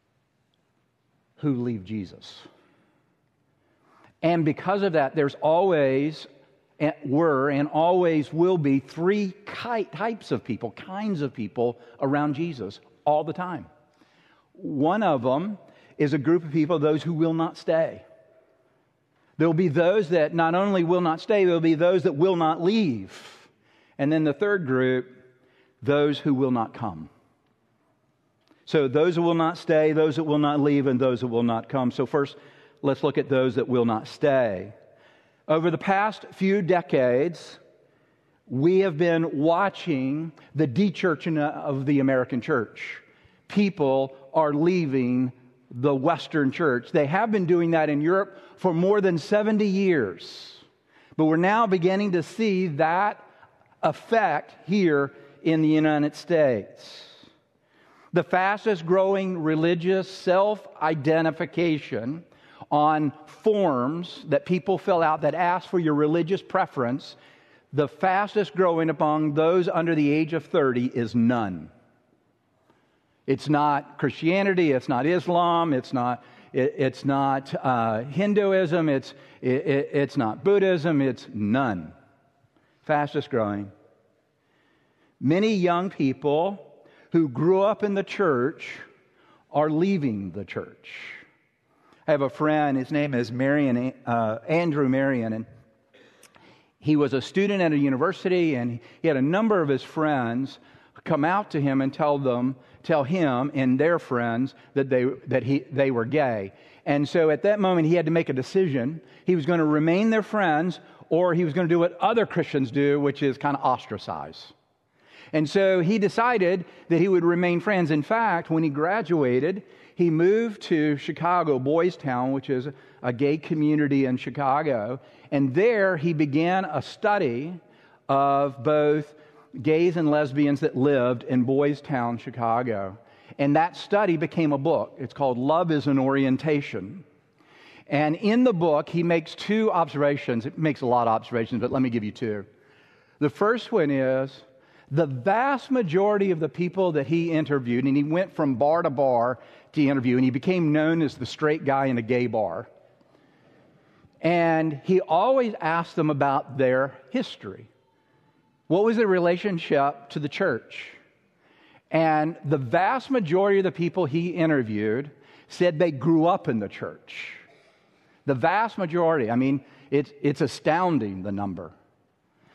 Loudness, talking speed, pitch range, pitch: -24 LUFS, 150 wpm, 135-175 Hz, 155 Hz